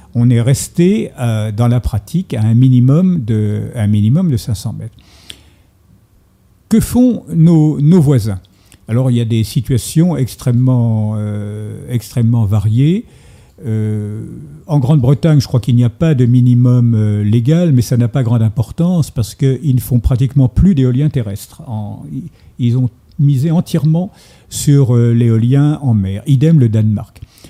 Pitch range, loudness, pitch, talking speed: 110-145 Hz, -13 LUFS, 120 Hz, 155 wpm